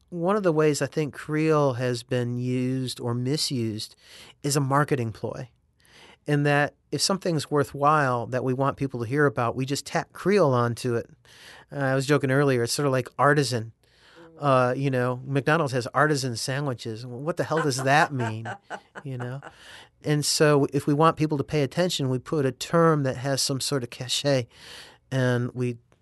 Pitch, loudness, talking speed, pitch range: 135 Hz, -25 LUFS, 185 wpm, 125-150 Hz